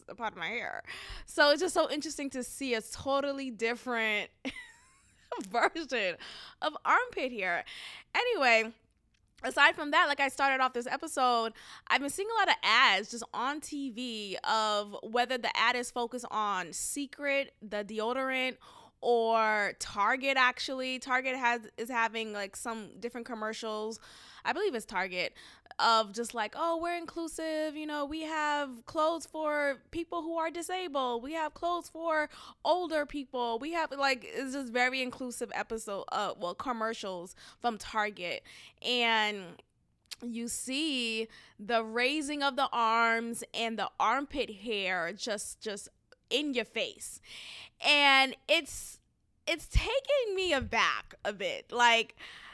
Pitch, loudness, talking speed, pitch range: 255 Hz, -31 LUFS, 145 wpm, 225-295 Hz